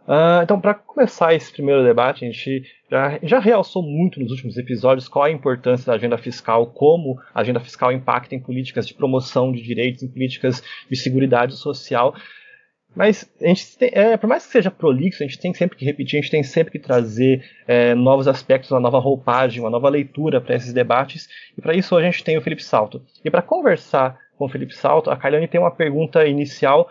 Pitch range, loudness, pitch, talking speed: 130-170 Hz, -18 LUFS, 140 Hz, 210 wpm